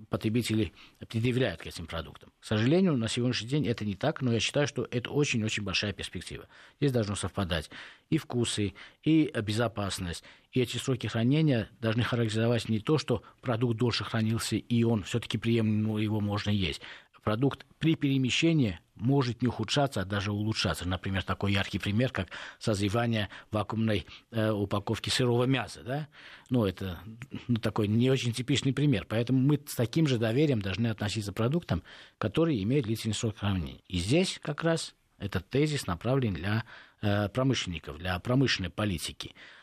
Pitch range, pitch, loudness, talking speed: 100-130 Hz, 115 Hz, -30 LUFS, 155 wpm